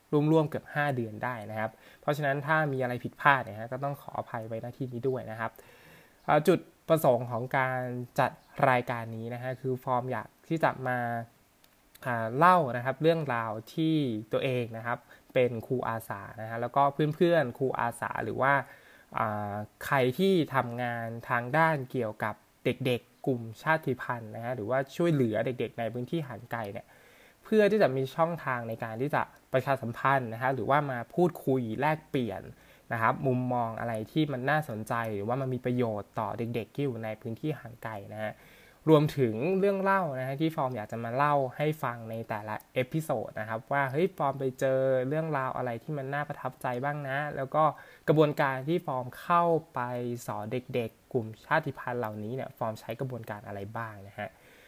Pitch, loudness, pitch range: 125 Hz, -30 LUFS, 115-145 Hz